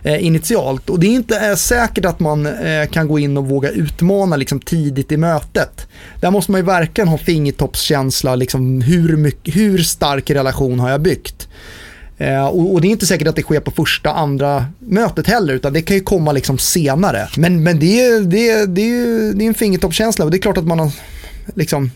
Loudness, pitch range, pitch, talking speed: -15 LUFS, 140-195 Hz, 160 Hz, 210 wpm